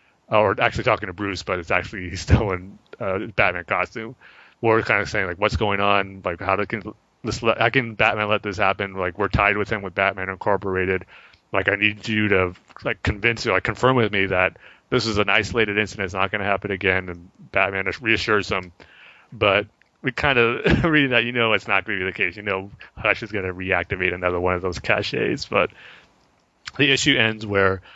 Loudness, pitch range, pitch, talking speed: -21 LUFS, 95-110 Hz, 100 Hz, 215 wpm